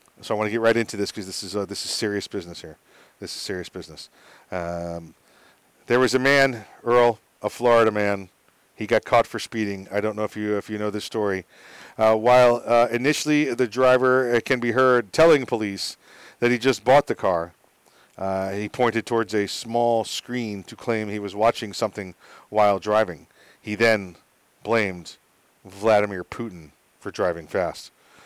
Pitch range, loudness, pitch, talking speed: 100-120 Hz, -22 LUFS, 105 Hz, 180 wpm